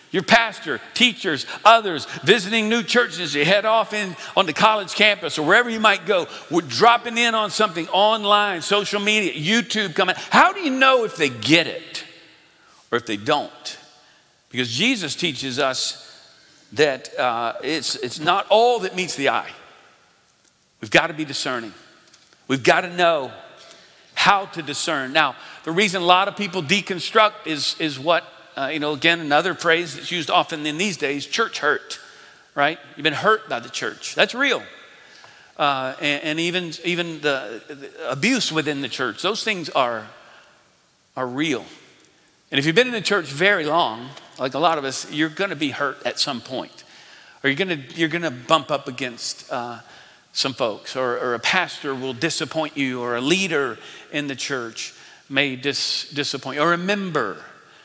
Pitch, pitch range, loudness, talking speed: 165 Hz, 145-205 Hz, -20 LUFS, 175 wpm